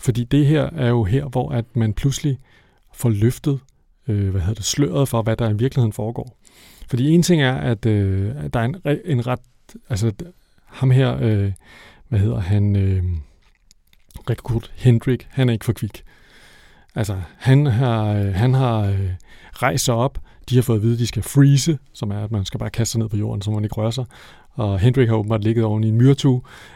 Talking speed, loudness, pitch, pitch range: 210 wpm, -20 LUFS, 115 Hz, 105-130 Hz